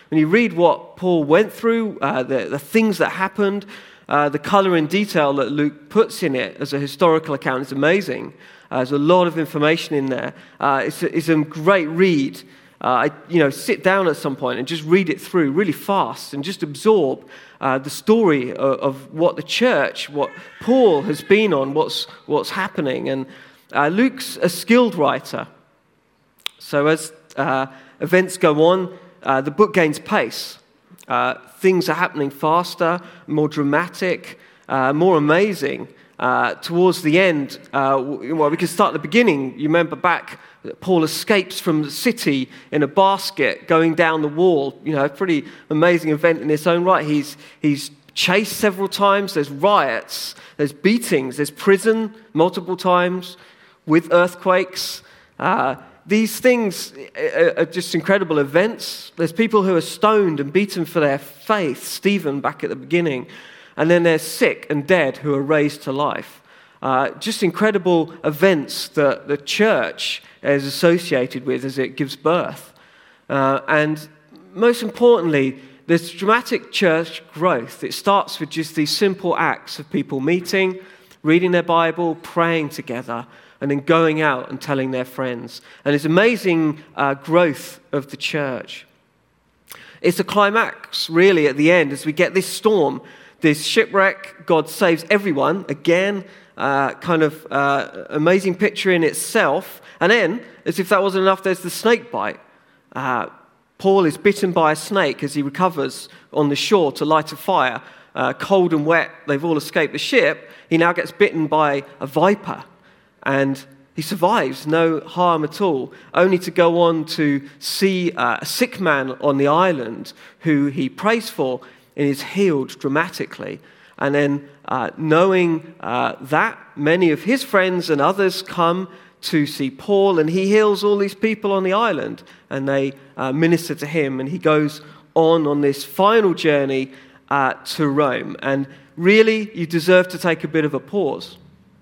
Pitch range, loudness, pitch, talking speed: 145-190 Hz, -19 LUFS, 165 Hz, 165 wpm